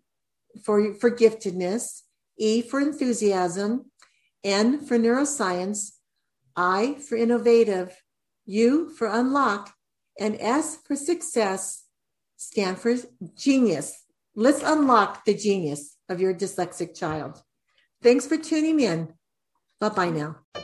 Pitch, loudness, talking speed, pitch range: 220 Hz, -24 LUFS, 105 wpm, 185-245 Hz